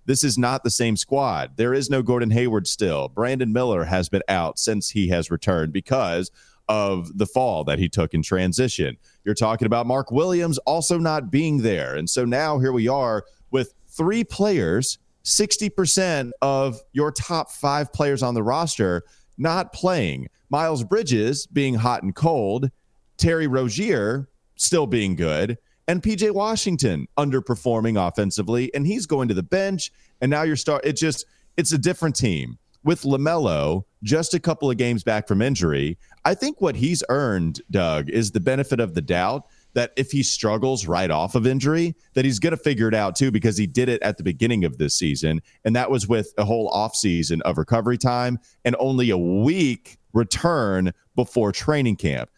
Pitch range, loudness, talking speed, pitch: 105-145 Hz, -22 LUFS, 180 wpm, 125 Hz